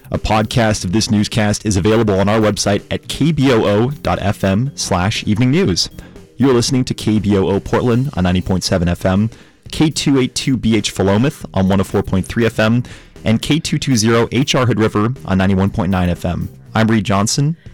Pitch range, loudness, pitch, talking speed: 95-120 Hz, -15 LUFS, 110 Hz, 130 wpm